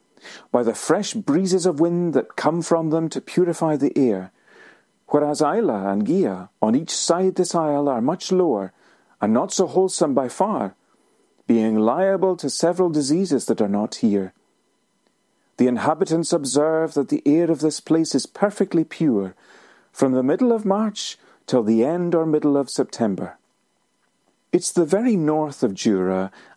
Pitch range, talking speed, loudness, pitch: 135-185 Hz, 160 wpm, -21 LUFS, 160 Hz